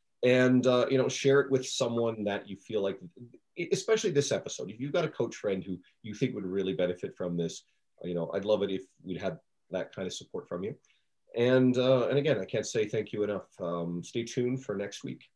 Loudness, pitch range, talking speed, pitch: -30 LUFS, 95-130 Hz, 230 wpm, 115 Hz